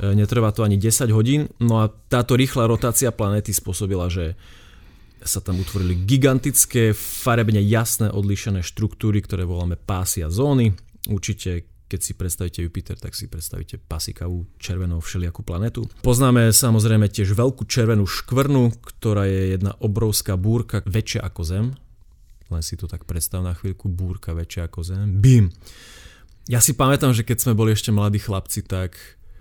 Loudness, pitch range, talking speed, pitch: -21 LUFS, 95-115 Hz, 155 wpm, 105 Hz